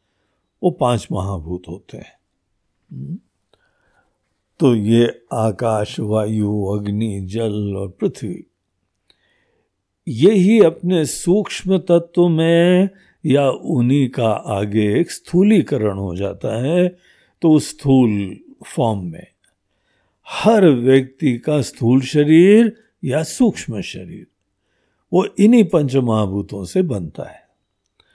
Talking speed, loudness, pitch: 100 wpm, -17 LUFS, 130 Hz